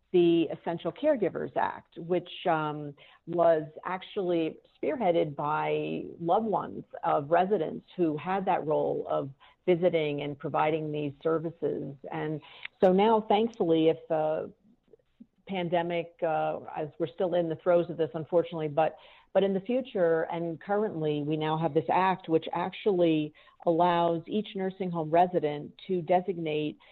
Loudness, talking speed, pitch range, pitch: -29 LUFS, 140 wpm, 155-185 Hz, 170 Hz